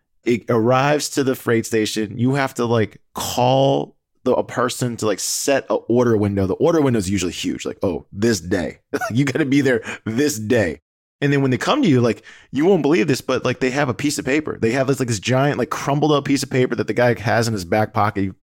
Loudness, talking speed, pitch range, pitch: -19 LUFS, 250 wpm, 110-135 Hz, 120 Hz